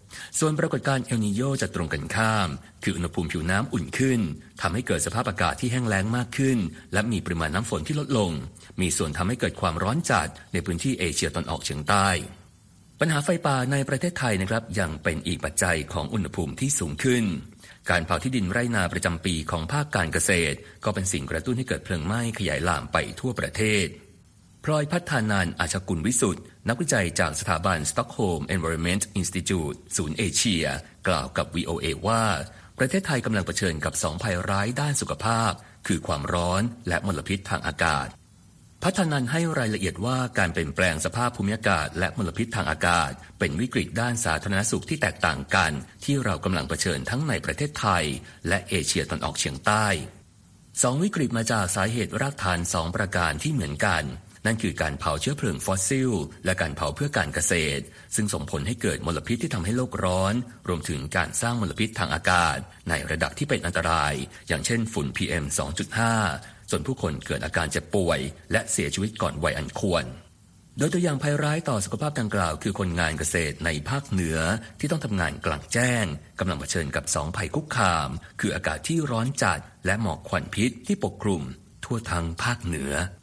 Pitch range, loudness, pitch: 85-115 Hz, -26 LUFS, 100 Hz